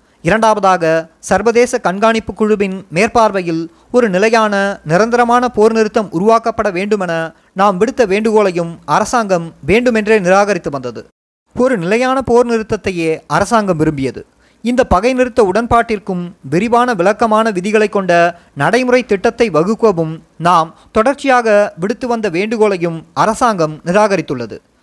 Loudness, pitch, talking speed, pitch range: -13 LUFS, 215 Hz, 105 wpm, 175-230 Hz